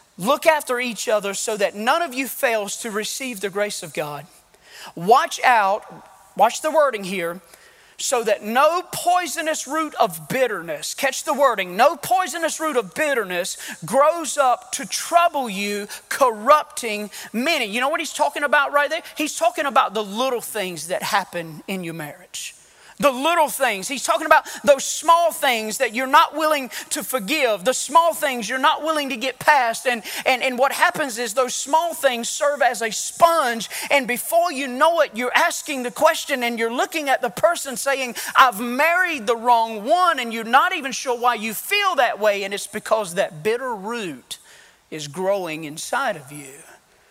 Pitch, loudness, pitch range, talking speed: 260 Hz, -20 LUFS, 215-310 Hz, 180 wpm